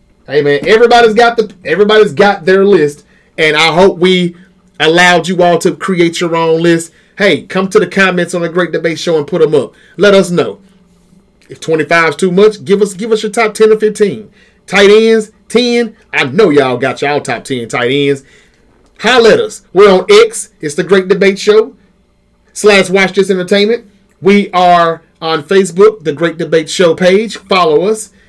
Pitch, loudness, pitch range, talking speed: 195 Hz, -9 LUFS, 170-215 Hz, 190 wpm